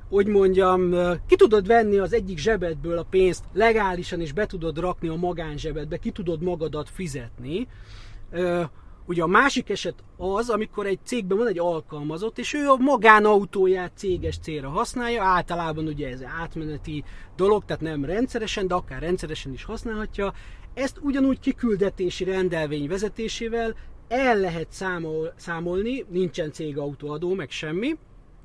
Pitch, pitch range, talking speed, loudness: 180 Hz, 160-215 Hz, 140 wpm, -24 LUFS